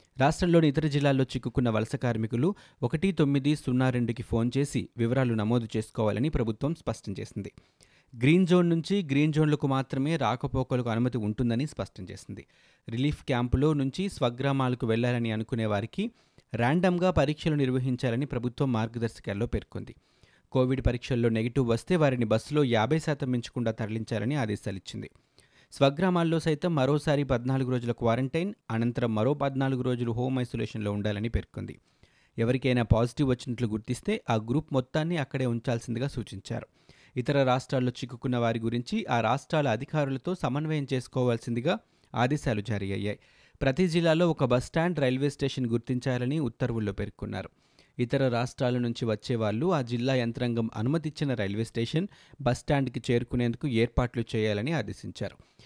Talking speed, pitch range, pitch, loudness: 125 wpm, 115-140 Hz, 125 Hz, -28 LUFS